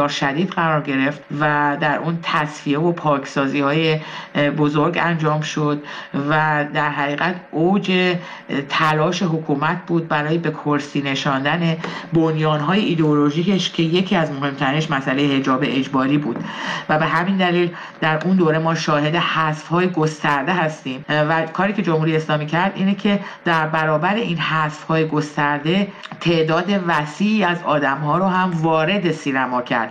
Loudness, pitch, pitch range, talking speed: -19 LUFS, 155 Hz, 150-170 Hz, 145 wpm